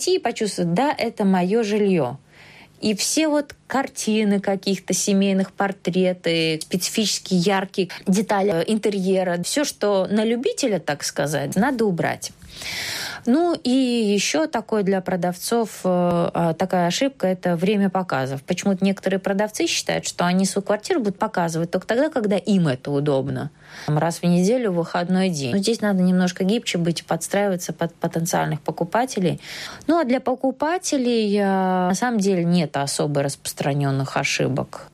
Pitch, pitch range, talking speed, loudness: 190 Hz, 170-215 Hz, 135 wpm, -21 LUFS